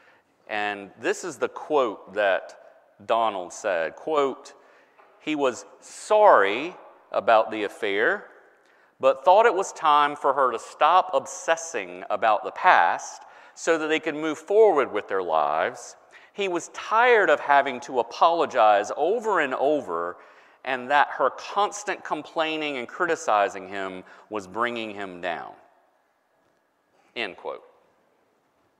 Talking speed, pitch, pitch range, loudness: 125 wpm, 155 Hz, 120-200 Hz, -23 LUFS